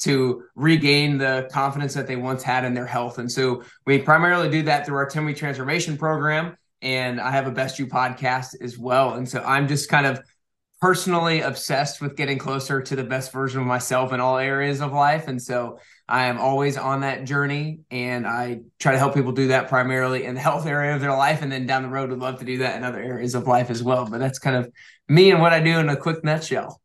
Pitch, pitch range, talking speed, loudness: 135 Hz, 125-145 Hz, 240 wpm, -22 LUFS